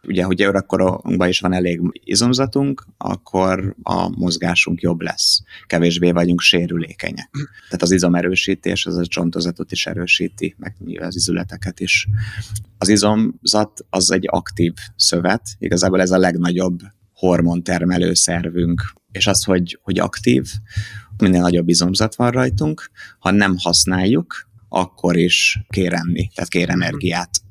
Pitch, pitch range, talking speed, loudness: 90 Hz, 85-100 Hz, 130 wpm, -17 LUFS